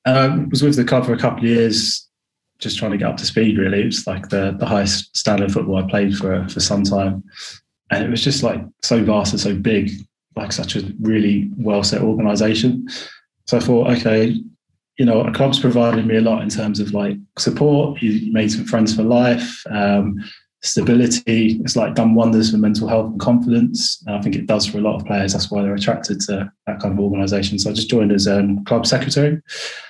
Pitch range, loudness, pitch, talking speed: 100-120 Hz, -17 LUFS, 110 Hz, 220 wpm